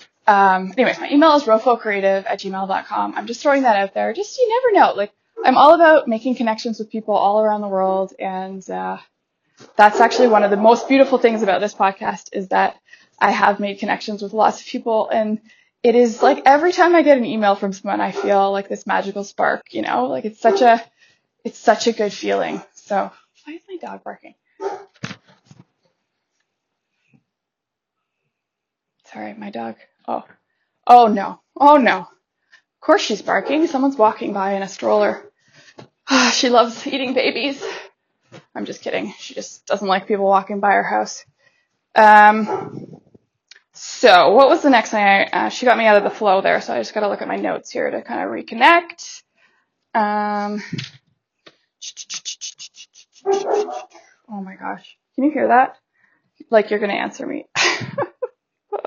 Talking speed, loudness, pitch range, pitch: 170 wpm, -16 LUFS, 200-270 Hz, 220 Hz